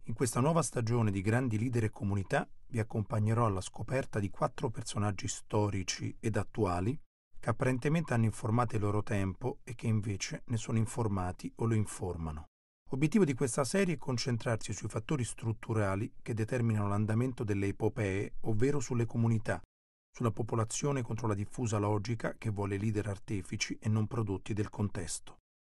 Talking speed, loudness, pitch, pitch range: 155 wpm, -34 LUFS, 110 Hz, 105-125 Hz